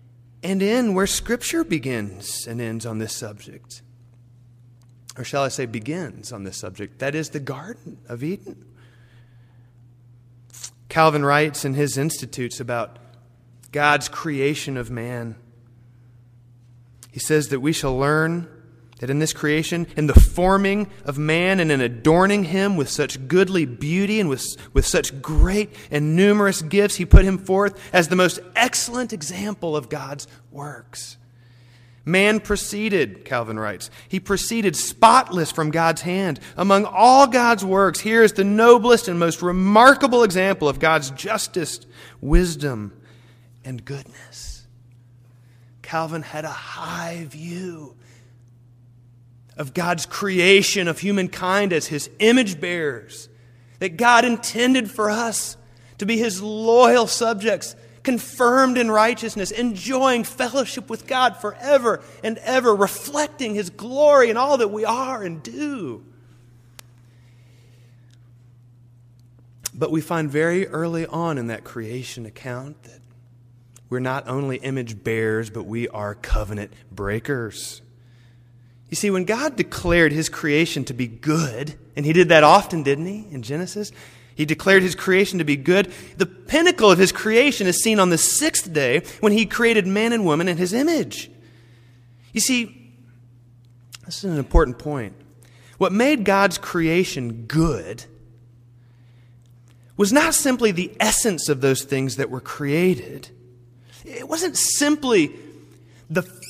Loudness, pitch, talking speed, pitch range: -20 LUFS, 150 Hz, 135 wpm, 120-195 Hz